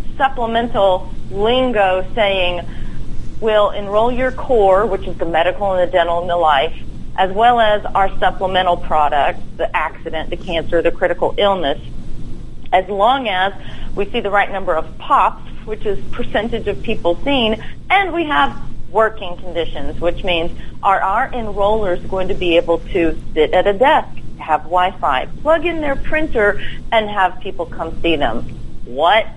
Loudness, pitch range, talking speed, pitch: -17 LUFS, 170-220 Hz, 160 wpm, 190 Hz